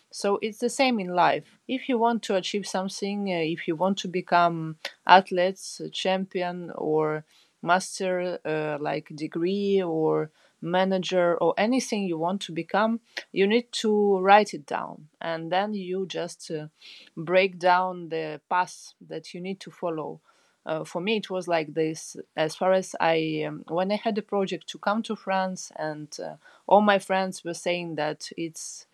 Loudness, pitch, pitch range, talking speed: -26 LUFS, 180 Hz, 165-195 Hz, 170 wpm